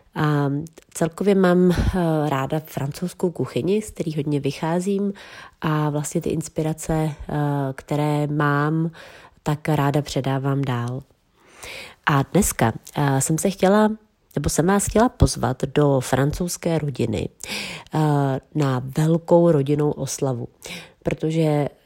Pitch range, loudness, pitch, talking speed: 140-170 Hz, -22 LUFS, 150 Hz, 105 wpm